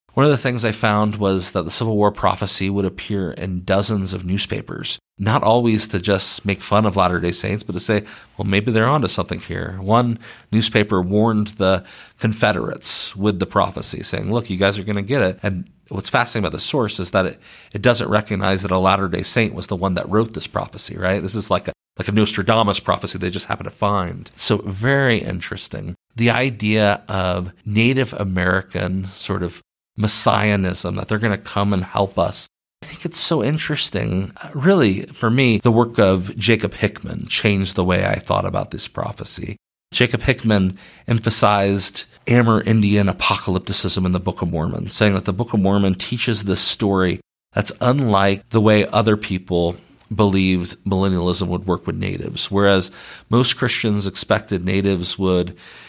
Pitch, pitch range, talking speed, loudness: 100 Hz, 95-110 Hz, 185 wpm, -19 LUFS